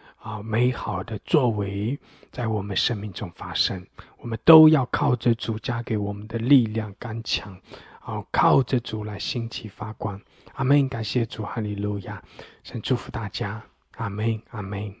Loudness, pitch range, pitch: -24 LUFS, 105-125 Hz, 110 Hz